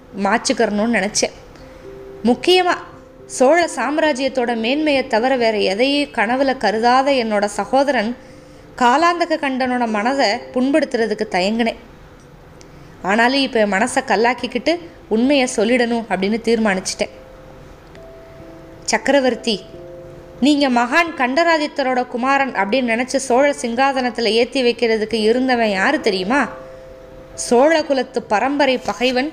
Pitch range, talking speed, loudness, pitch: 215-270 Hz, 90 wpm, -17 LUFS, 245 Hz